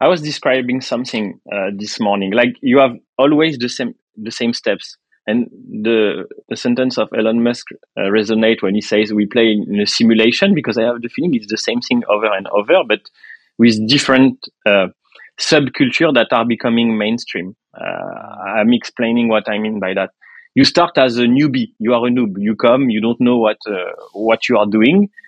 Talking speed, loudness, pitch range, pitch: 195 wpm, -15 LUFS, 110-130 Hz, 120 Hz